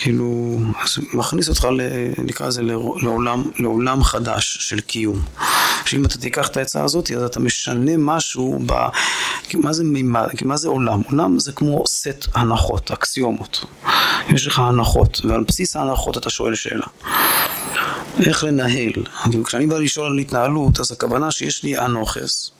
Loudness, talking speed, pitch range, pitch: -19 LUFS, 150 wpm, 115-145 Hz, 125 Hz